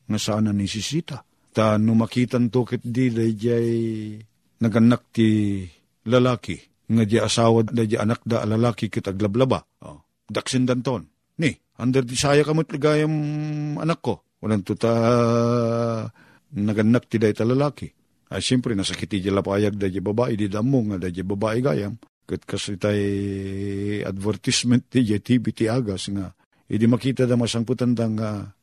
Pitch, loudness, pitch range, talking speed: 115 Hz, -22 LUFS, 105-125 Hz, 145 wpm